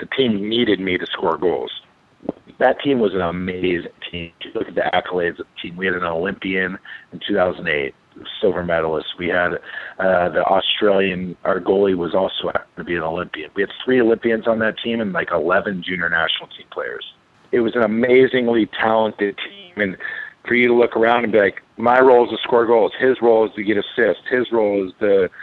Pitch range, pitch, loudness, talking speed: 95-120 Hz, 110 Hz, -19 LUFS, 205 wpm